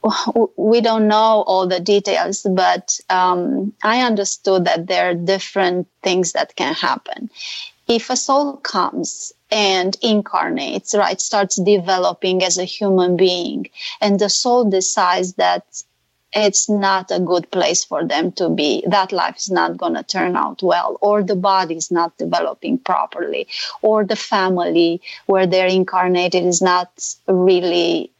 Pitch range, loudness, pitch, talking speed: 185-215 Hz, -17 LUFS, 195 Hz, 150 wpm